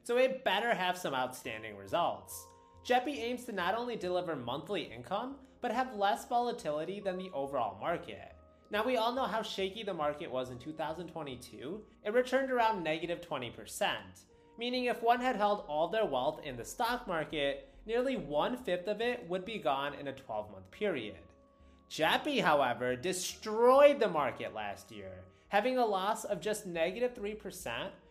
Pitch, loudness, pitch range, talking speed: 190 Hz, -34 LUFS, 140-235 Hz, 165 wpm